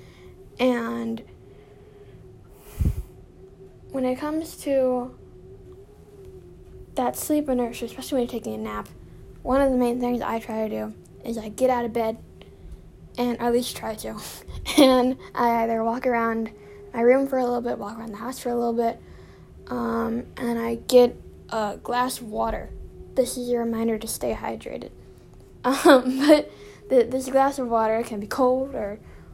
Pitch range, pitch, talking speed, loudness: 225-255 Hz, 240 Hz, 165 wpm, -24 LUFS